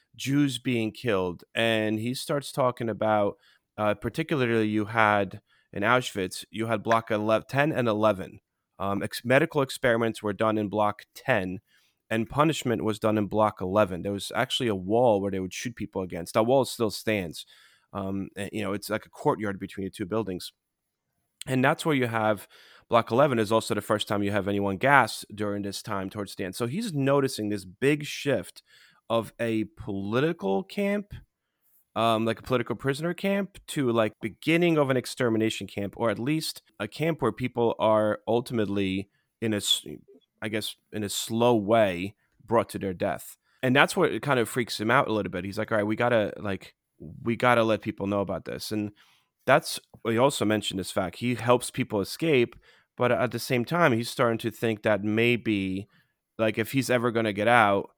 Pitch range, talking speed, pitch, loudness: 100-125 Hz, 190 wpm, 110 Hz, -27 LUFS